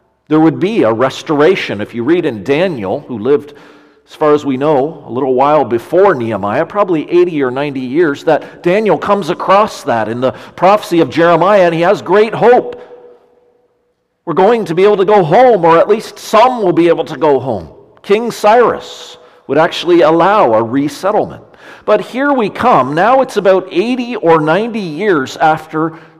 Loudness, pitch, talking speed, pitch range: -11 LUFS, 175 Hz, 180 wpm, 150-215 Hz